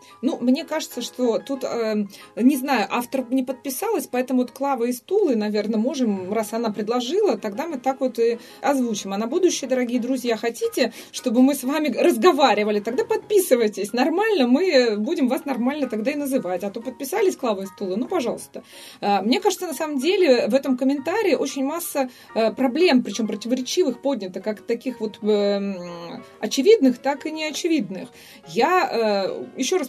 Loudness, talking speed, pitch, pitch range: -22 LUFS, 160 wpm, 255 Hz, 225-290 Hz